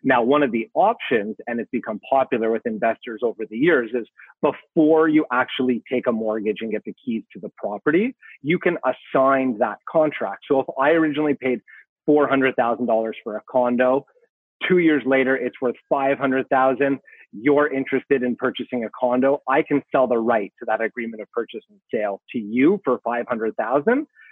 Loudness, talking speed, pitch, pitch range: -21 LUFS, 175 wpm, 135 Hz, 125-150 Hz